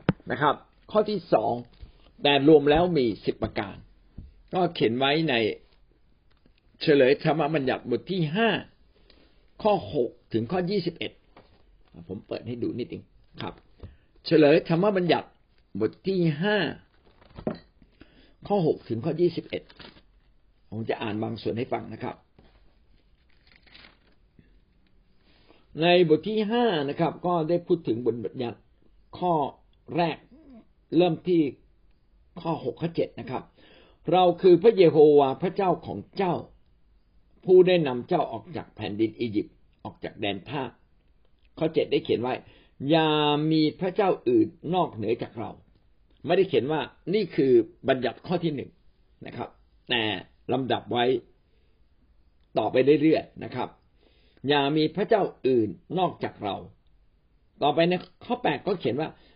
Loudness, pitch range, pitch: -25 LUFS, 110-185 Hz, 155 Hz